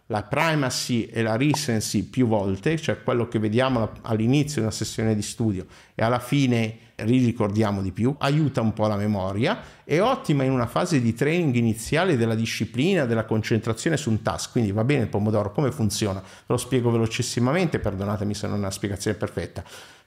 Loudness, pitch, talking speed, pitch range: -24 LUFS, 115 Hz, 180 wpm, 105-130 Hz